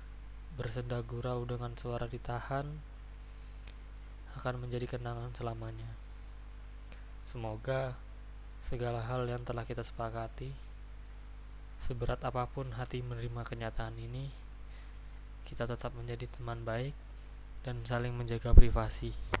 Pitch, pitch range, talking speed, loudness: 115 Hz, 115-125 Hz, 95 wpm, -38 LUFS